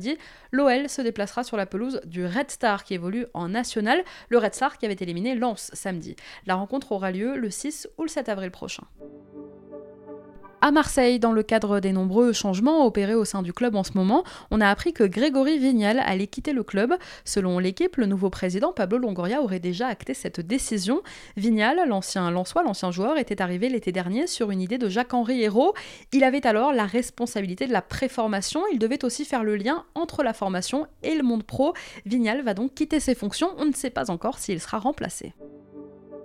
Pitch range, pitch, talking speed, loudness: 195-265 Hz, 230 Hz, 200 wpm, -25 LUFS